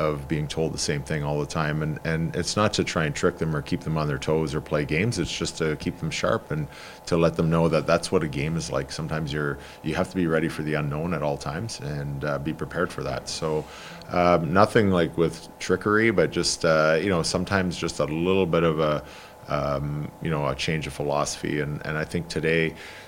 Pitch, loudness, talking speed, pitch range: 80 Hz, -25 LUFS, 245 wpm, 75-85 Hz